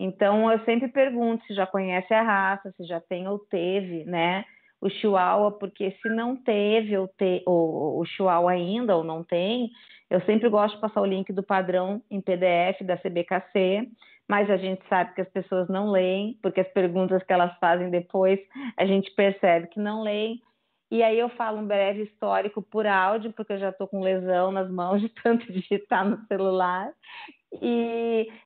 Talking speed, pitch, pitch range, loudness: 190 wpm, 195 Hz, 185-220 Hz, -25 LUFS